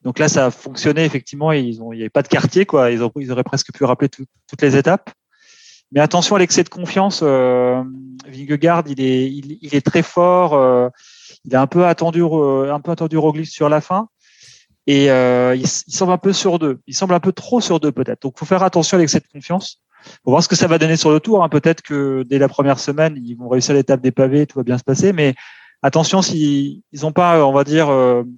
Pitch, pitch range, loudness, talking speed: 150 Hz, 135-170 Hz, -16 LUFS, 245 wpm